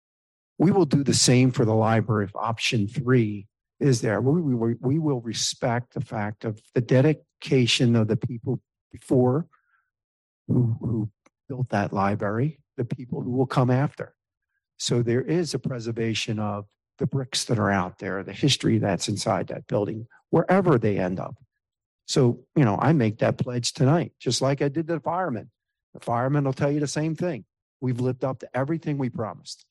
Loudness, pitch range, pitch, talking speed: -24 LUFS, 110-140 Hz, 125 Hz, 180 wpm